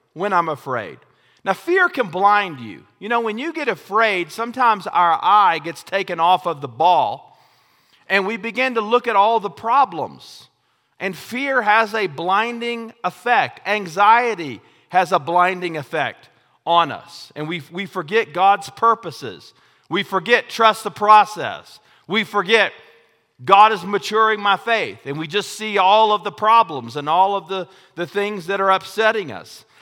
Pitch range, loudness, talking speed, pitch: 180-220 Hz, -18 LUFS, 165 wpm, 200 Hz